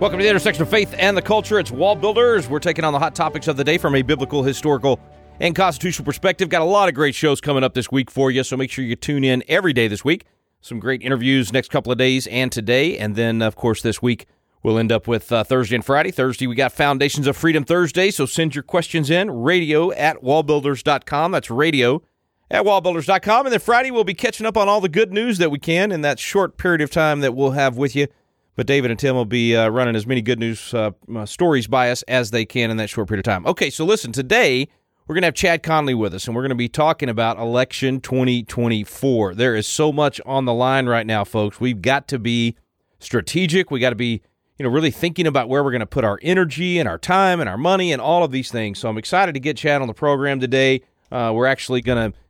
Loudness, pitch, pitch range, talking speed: -19 LUFS, 135 Hz, 120-165 Hz, 255 wpm